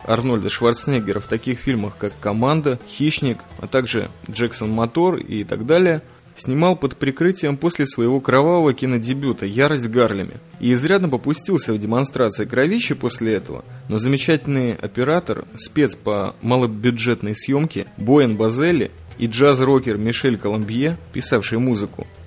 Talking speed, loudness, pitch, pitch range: 125 wpm, -19 LUFS, 125 Hz, 110-140 Hz